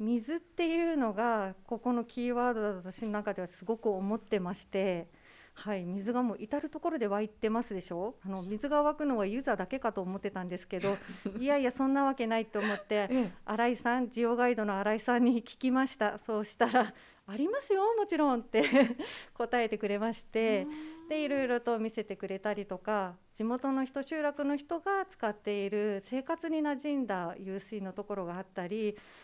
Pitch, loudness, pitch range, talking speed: 225 Hz, -33 LUFS, 205-265 Hz, 365 characters per minute